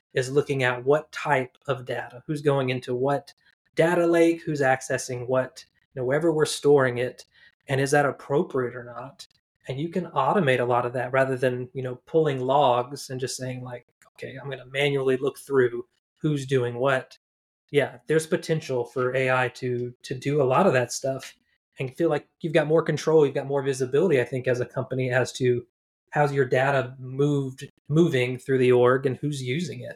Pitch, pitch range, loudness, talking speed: 135 Hz, 125-150 Hz, -25 LUFS, 200 wpm